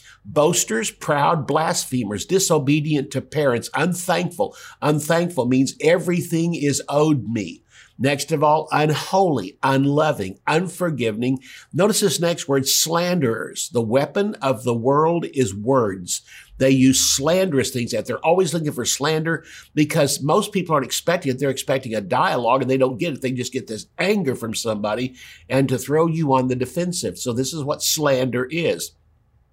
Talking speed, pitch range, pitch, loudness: 155 wpm, 130-165 Hz, 140 Hz, -20 LUFS